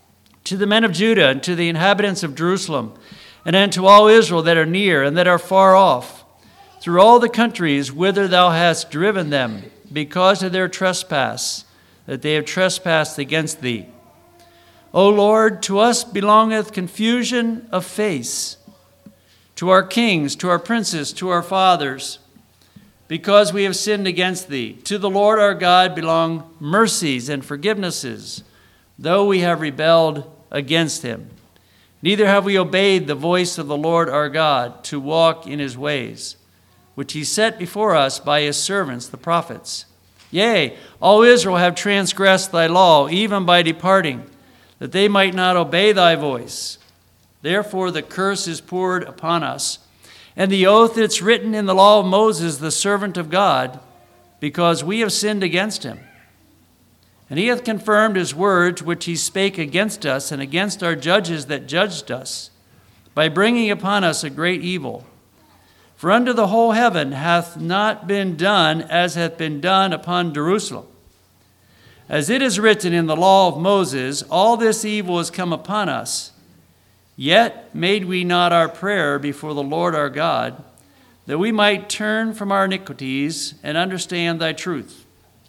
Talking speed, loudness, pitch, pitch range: 160 wpm, -17 LUFS, 175 Hz, 145-200 Hz